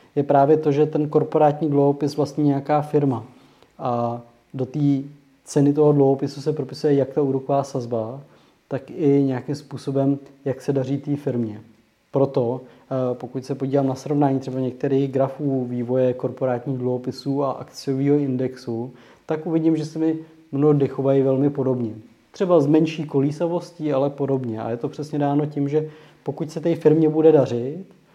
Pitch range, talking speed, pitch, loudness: 130-150 Hz, 160 wpm, 140 Hz, -22 LUFS